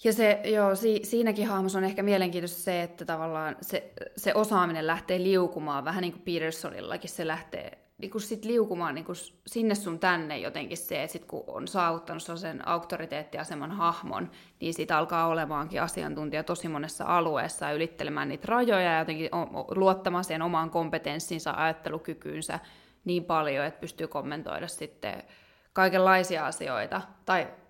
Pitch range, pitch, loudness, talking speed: 160-190 Hz, 170 Hz, -30 LUFS, 145 wpm